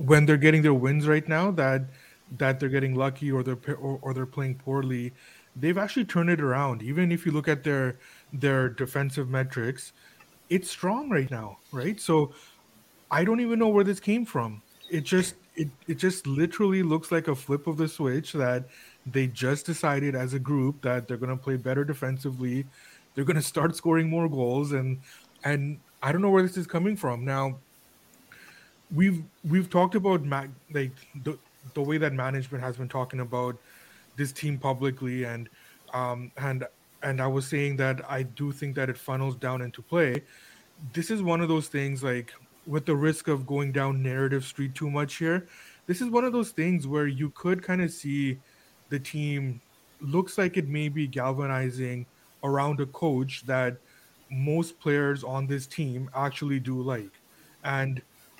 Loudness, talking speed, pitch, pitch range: -28 LUFS, 180 wpm, 140 Hz, 130-160 Hz